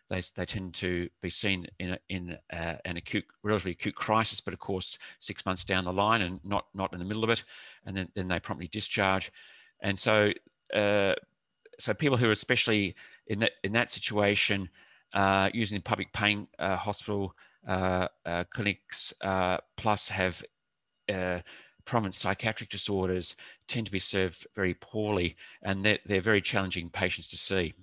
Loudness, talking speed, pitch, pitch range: -30 LUFS, 170 wpm, 95 Hz, 90-105 Hz